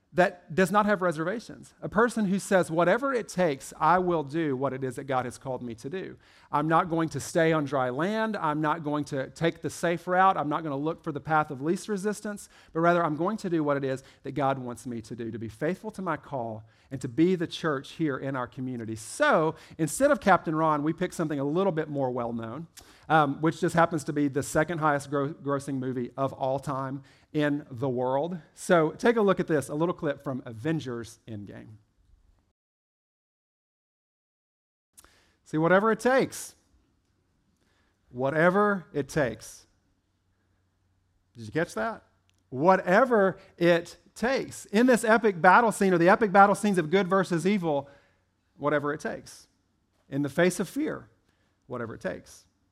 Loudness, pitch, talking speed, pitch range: -27 LUFS, 150 Hz, 190 wpm, 125-180 Hz